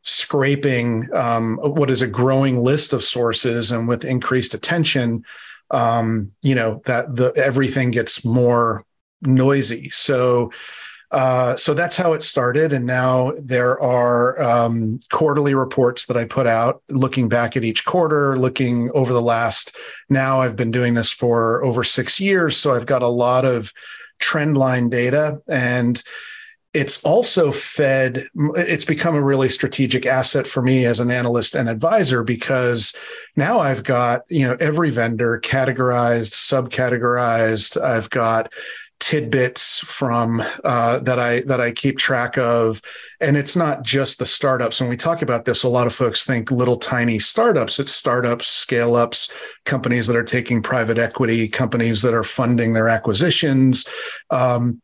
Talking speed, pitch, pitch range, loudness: 155 wpm, 125 Hz, 120-135 Hz, -18 LUFS